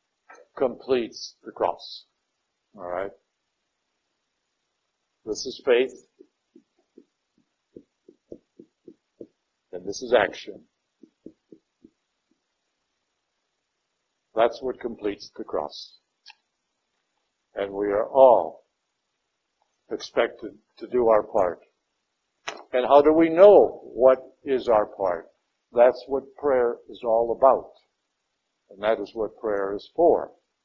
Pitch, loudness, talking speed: 130 Hz, -23 LUFS, 90 wpm